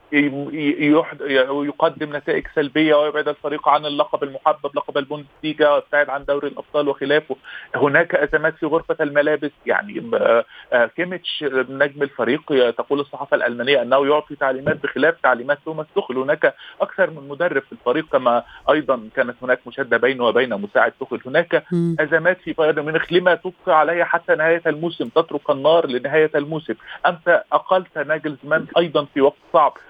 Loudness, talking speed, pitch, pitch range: -19 LUFS, 140 wpm, 150 Hz, 140-160 Hz